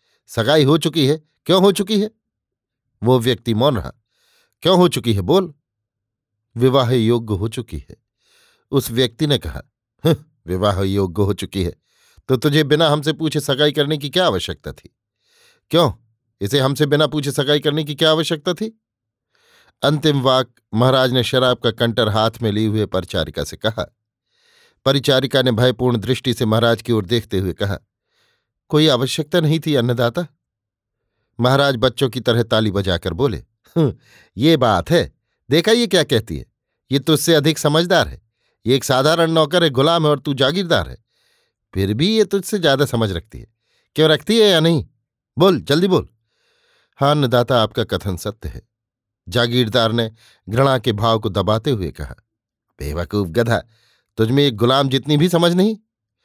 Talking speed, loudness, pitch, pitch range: 165 wpm, -17 LUFS, 130 Hz, 110-155 Hz